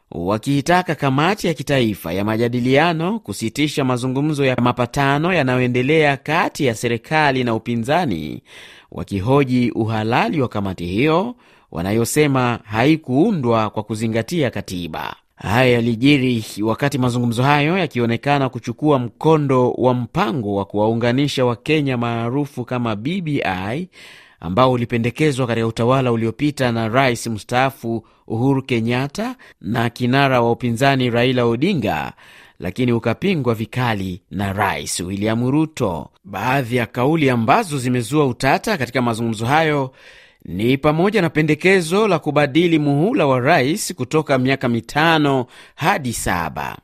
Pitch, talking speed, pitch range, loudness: 125 Hz, 115 wpm, 115-145 Hz, -18 LUFS